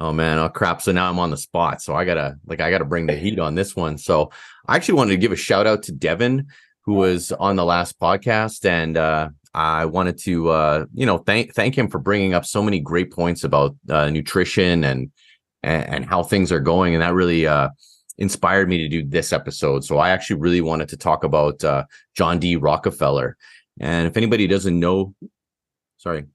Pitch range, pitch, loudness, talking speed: 80-95 Hz, 85 Hz, -20 LUFS, 215 wpm